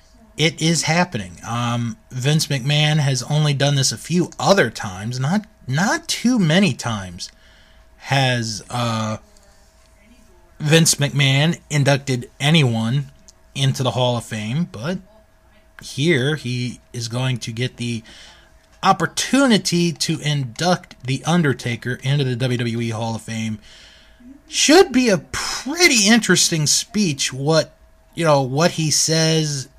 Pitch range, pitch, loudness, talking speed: 120-165 Hz, 140 Hz, -18 LUFS, 125 wpm